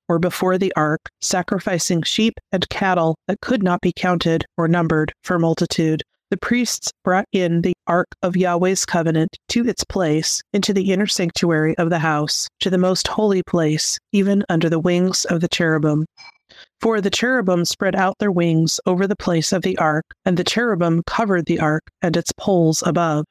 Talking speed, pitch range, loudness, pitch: 185 wpm, 165-190 Hz, -19 LUFS, 180 Hz